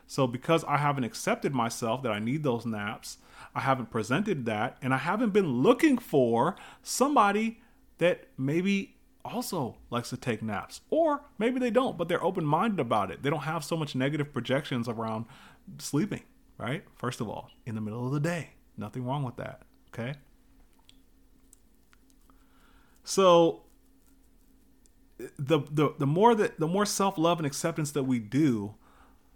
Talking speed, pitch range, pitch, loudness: 155 wpm, 125-205 Hz, 150 Hz, -29 LUFS